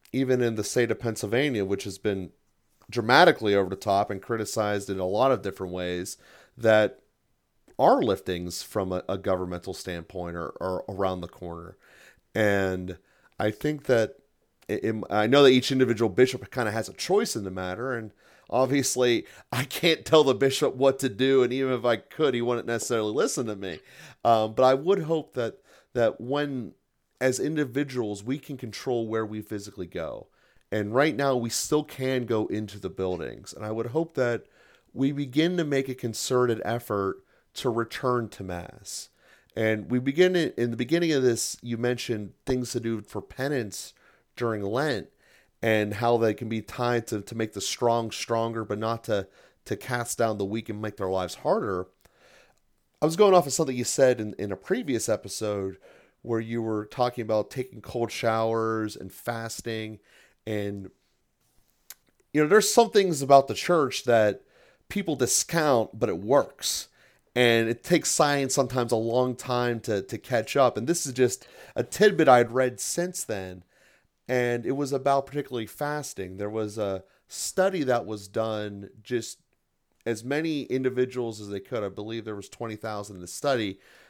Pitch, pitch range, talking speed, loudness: 115 Hz, 105-130 Hz, 175 wpm, -26 LUFS